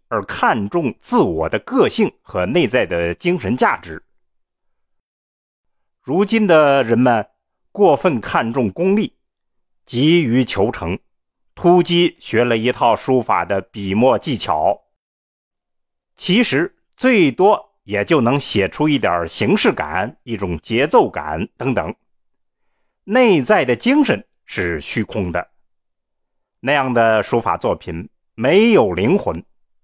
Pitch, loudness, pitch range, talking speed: 120 Hz, -17 LUFS, 95-155 Hz, 170 characters per minute